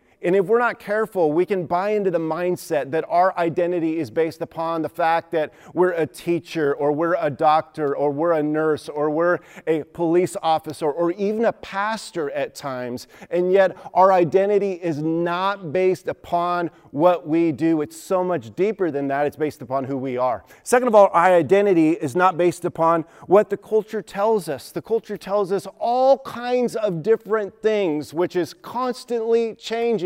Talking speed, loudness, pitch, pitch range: 185 wpm, -21 LUFS, 175 Hz, 160-200 Hz